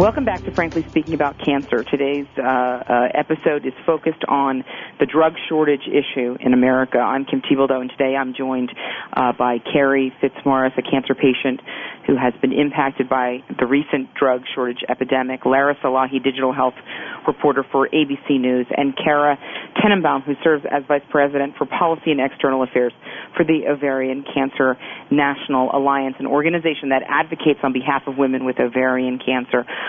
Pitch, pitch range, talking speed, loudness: 135 Hz, 130-145 Hz, 165 wpm, -19 LUFS